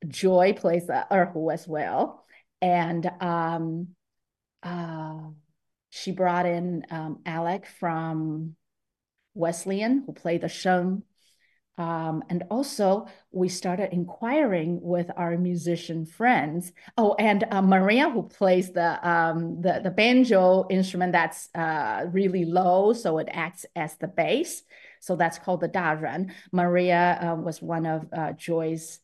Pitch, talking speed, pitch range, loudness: 175 Hz, 130 wpm, 165-190 Hz, -25 LUFS